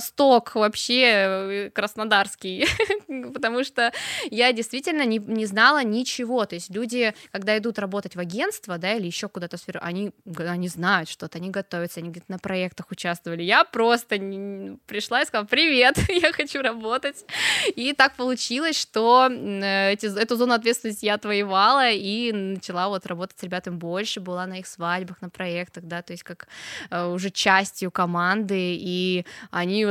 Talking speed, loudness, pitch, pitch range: 135 wpm, -23 LUFS, 200 Hz, 180-235 Hz